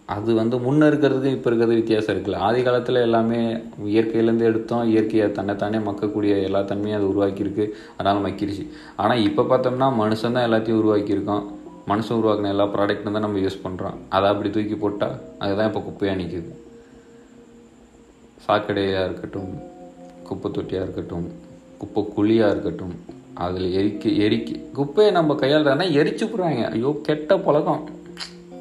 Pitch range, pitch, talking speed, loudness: 100-125 Hz, 105 Hz, 135 wpm, -21 LUFS